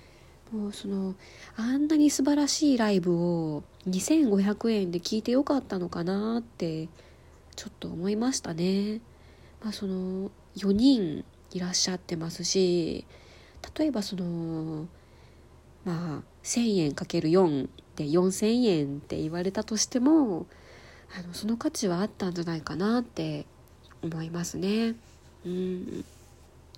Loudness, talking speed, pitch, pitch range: -28 LUFS, 230 characters per minute, 185 Hz, 165-220 Hz